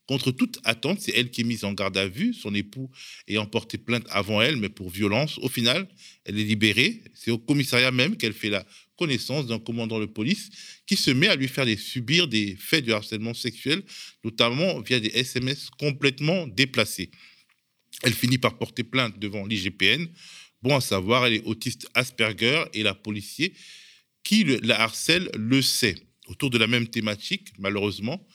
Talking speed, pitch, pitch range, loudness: 180 wpm, 120 Hz, 110-140 Hz, -24 LUFS